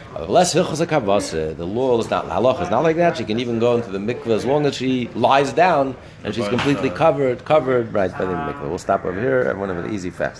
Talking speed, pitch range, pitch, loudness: 225 wpm, 105-140 Hz, 125 Hz, -19 LUFS